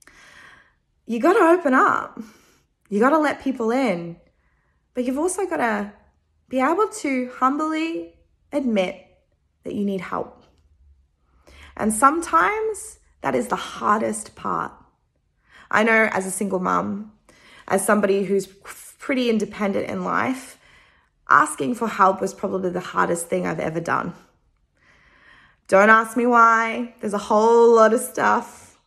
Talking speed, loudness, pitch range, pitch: 135 wpm, -20 LUFS, 195-265 Hz, 225 Hz